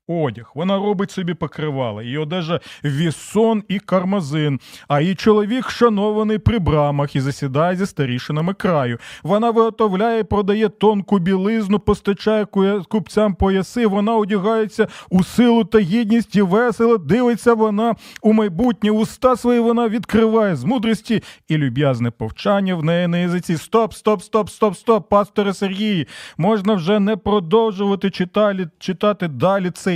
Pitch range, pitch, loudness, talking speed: 175-220 Hz, 205 Hz, -18 LUFS, 140 wpm